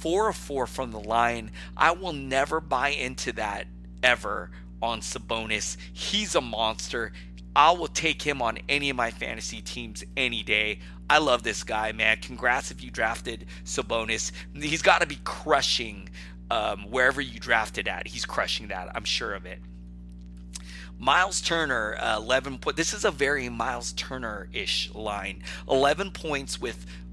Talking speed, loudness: 160 wpm, -26 LUFS